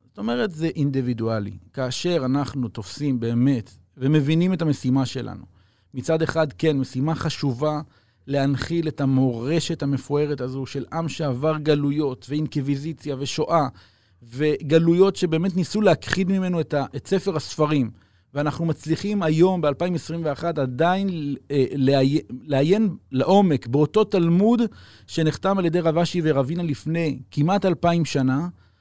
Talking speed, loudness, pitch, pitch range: 125 wpm, -22 LUFS, 150 Hz, 130-165 Hz